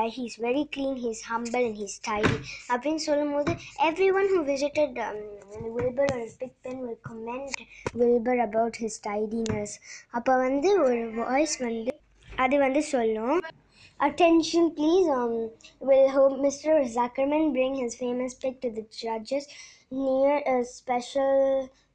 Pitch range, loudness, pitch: 235-285 Hz, -26 LUFS, 260 Hz